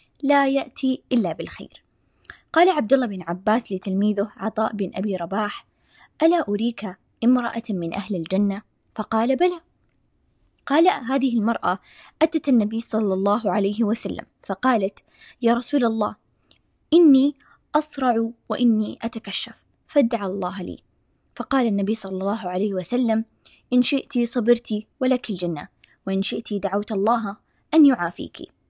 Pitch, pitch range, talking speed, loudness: 225 Hz, 200-260 Hz, 125 wpm, -22 LUFS